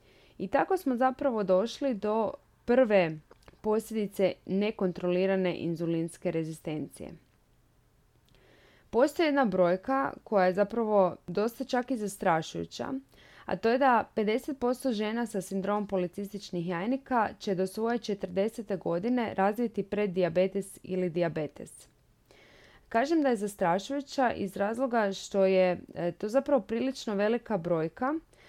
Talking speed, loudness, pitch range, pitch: 115 wpm, -30 LUFS, 185-240 Hz, 205 Hz